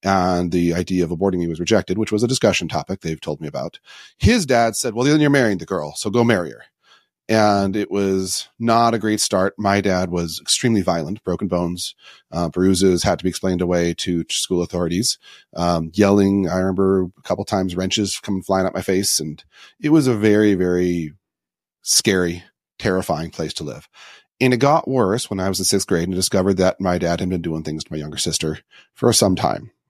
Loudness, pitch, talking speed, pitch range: -19 LUFS, 95 Hz, 210 wpm, 85-105 Hz